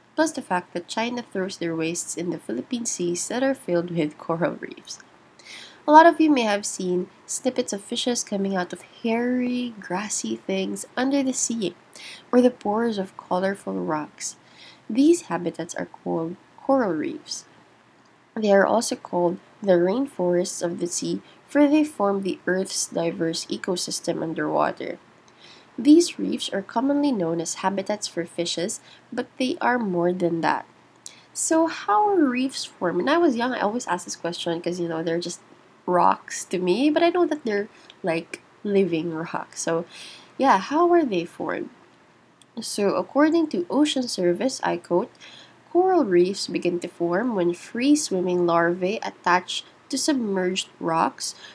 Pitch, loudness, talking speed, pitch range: 195 Hz, -24 LUFS, 160 wpm, 175-260 Hz